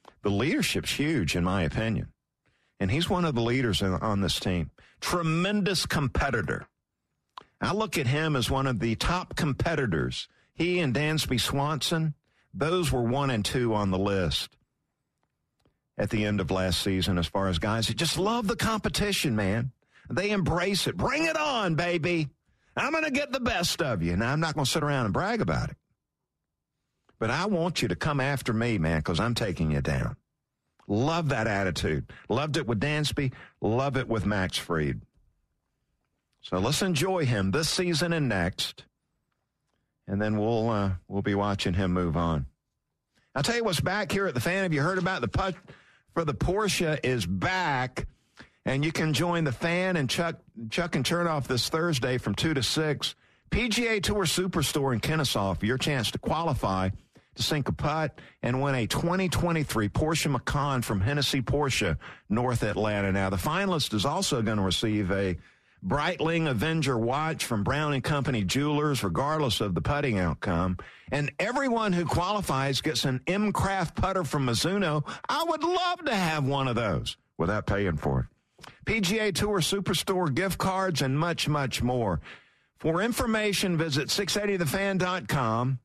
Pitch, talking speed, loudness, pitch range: 140 Hz, 170 wpm, -27 LUFS, 110-175 Hz